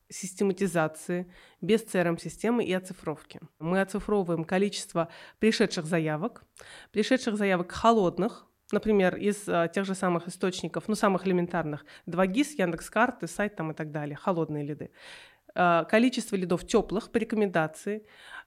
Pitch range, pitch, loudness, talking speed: 170-210 Hz, 190 Hz, -28 LUFS, 125 wpm